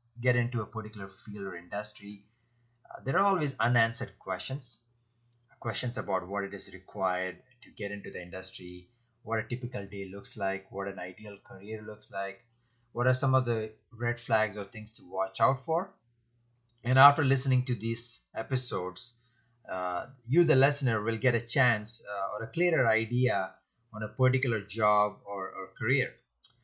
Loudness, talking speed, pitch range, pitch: -30 LUFS, 170 wpm, 100-125 Hz, 115 Hz